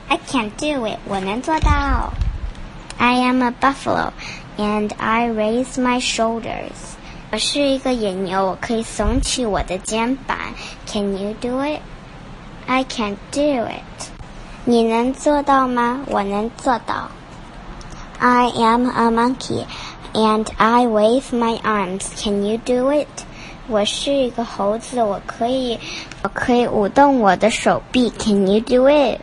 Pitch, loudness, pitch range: 230 Hz, -19 LUFS, 210-255 Hz